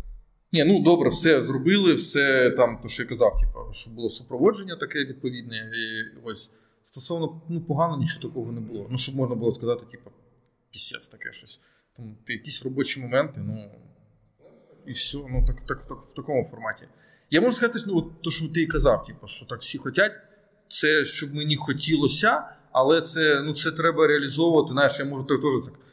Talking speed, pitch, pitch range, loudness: 185 wpm, 140 Hz, 120-165 Hz, -24 LUFS